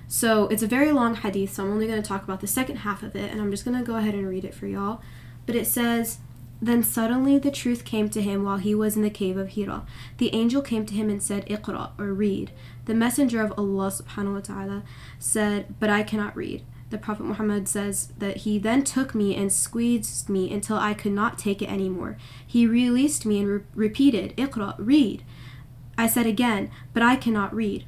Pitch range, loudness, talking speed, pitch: 195-230 Hz, -25 LUFS, 215 wpm, 210 Hz